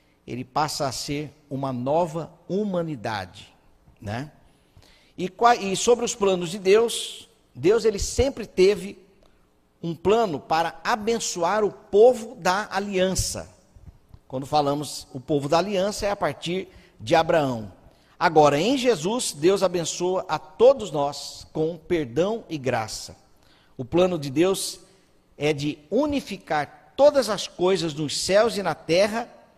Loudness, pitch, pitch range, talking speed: -23 LUFS, 175 Hz, 145-205 Hz, 130 wpm